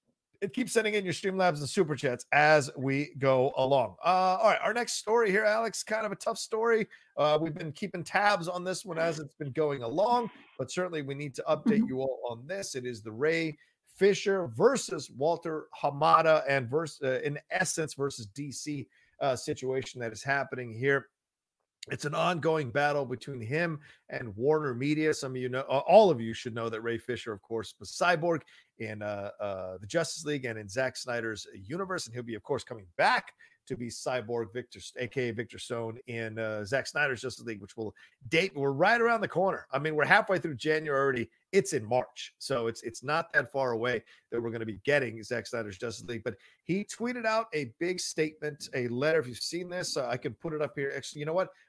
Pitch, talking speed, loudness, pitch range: 145 Hz, 215 wpm, -30 LUFS, 120-170 Hz